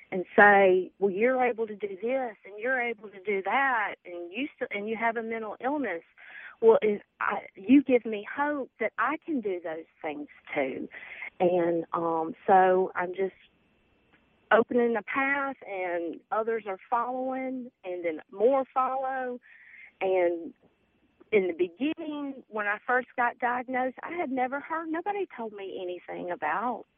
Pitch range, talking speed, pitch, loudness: 190-260 Hz, 155 wpm, 230 Hz, -28 LUFS